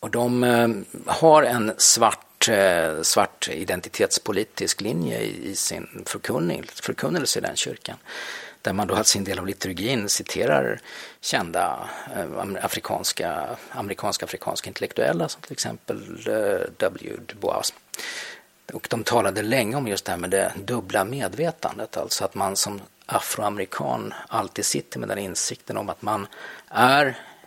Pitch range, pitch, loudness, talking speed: 100-155 Hz, 110 Hz, -24 LUFS, 125 wpm